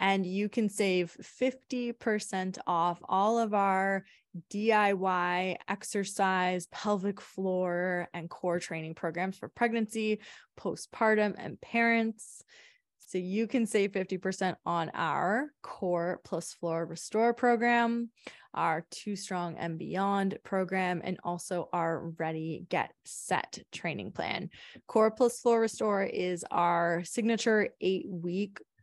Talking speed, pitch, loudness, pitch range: 120 wpm, 190 Hz, -31 LUFS, 175-220 Hz